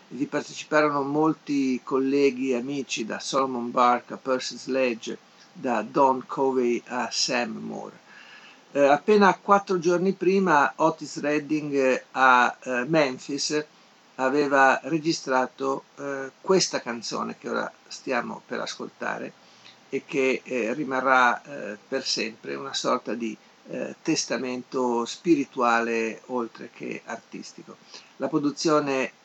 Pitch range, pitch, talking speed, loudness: 125-150 Hz, 135 Hz, 115 wpm, -25 LUFS